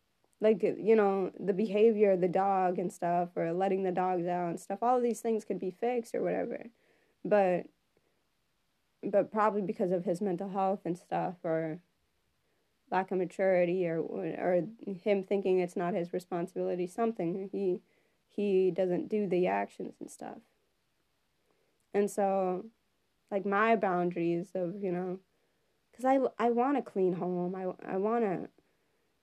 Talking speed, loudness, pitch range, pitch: 150 wpm, -31 LUFS, 180-210 Hz, 190 Hz